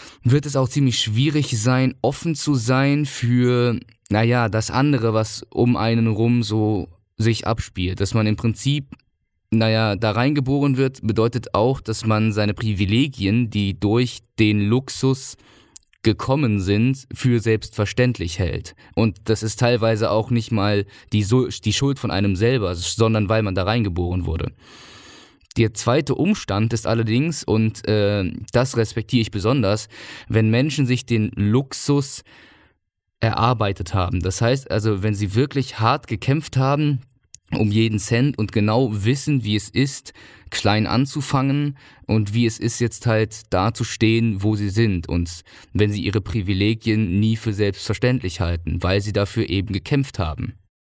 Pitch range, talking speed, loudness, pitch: 105-125 Hz, 150 wpm, -20 LUFS, 115 Hz